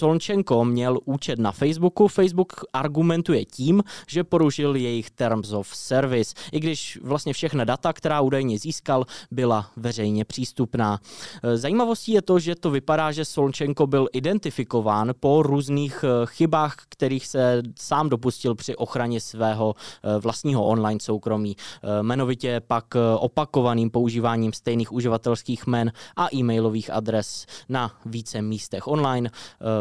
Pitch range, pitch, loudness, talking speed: 115-150 Hz, 125 Hz, -24 LUFS, 125 wpm